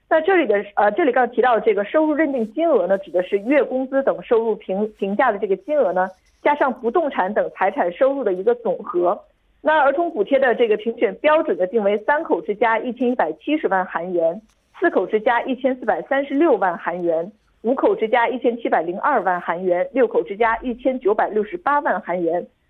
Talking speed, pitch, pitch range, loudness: 325 characters per minute, 245 Hz, 205-300 Hz, -20 LUFS